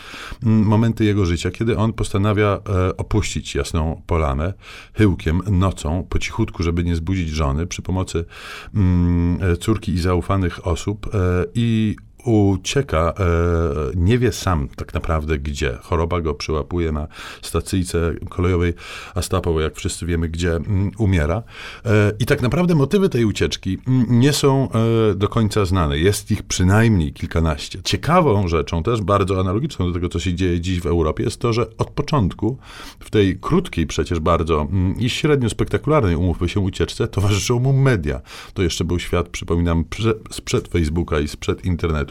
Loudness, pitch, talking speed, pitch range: -20 LUFS, 95 Hz, 160 wpm, 85-105 Hz